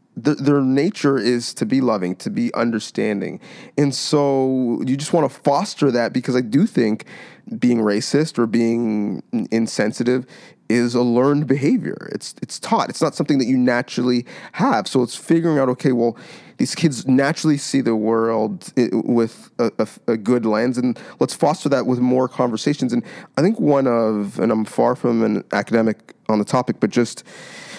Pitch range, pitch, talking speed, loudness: 115-140 Hz, 125 Hz, 175 wpm, -19 LUFS